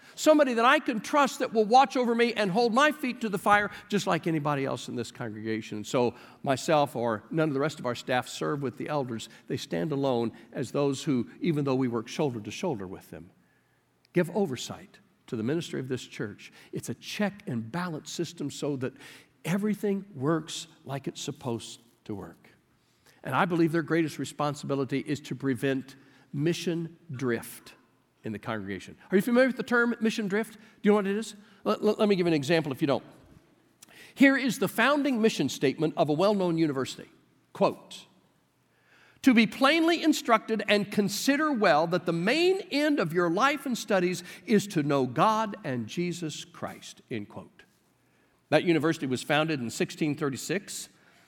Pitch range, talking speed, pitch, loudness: 135-210 Hz, 185 wpm, 165 Hz, -28 LUFS